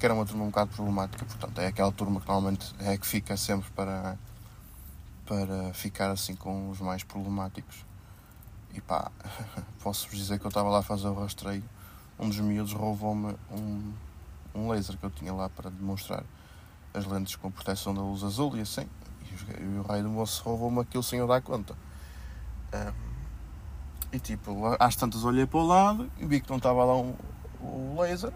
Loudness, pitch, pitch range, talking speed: -31 LUFS, 100 Hz, 95-110 Hz, 195 wpm